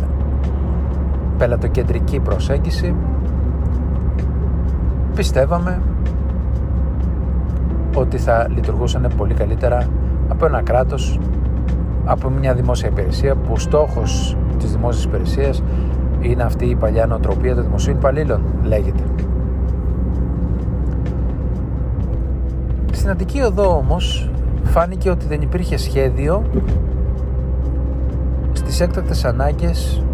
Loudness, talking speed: -19 LUFS, 85 wpm